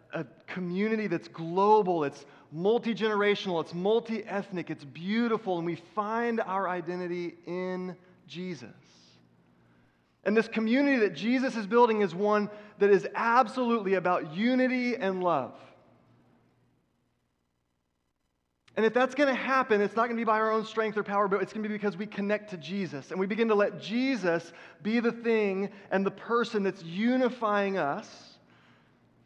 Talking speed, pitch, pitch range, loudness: 150 wpm, 200 Hz, 170-220 Hz, -29 LUFS